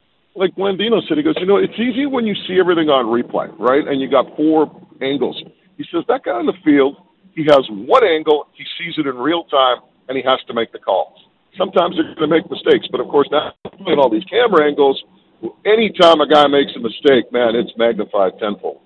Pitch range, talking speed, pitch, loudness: 135-190 Hz, 225 wpm, 150 Hz, -16 LUFS